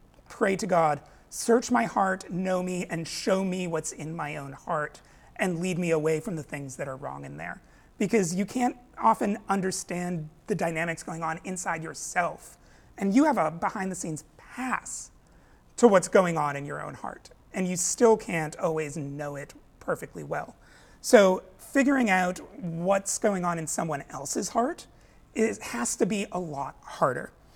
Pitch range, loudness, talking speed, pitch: 160-210 Hz, -28 LUFS, 175 wpm, 180 Hz